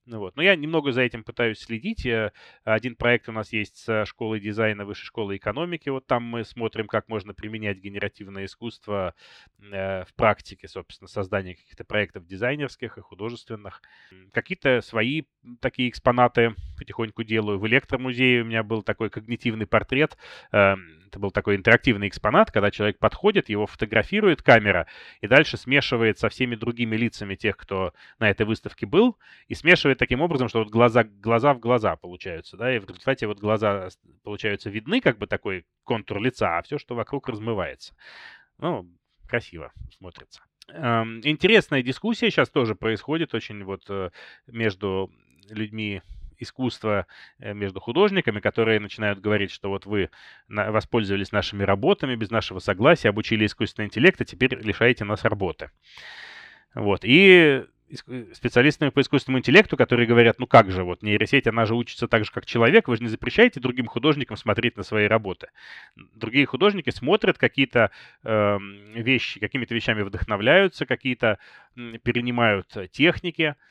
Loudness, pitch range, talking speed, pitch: -22 LUFS, 105-125 Hz, 150 wpm, 115 Hz